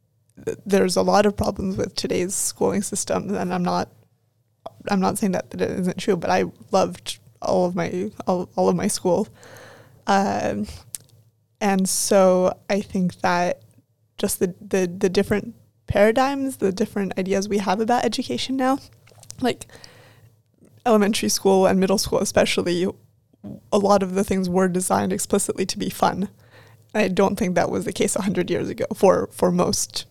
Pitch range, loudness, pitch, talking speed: 130-205 Hz, -22 LUFS, 190 Hz, 165 wpm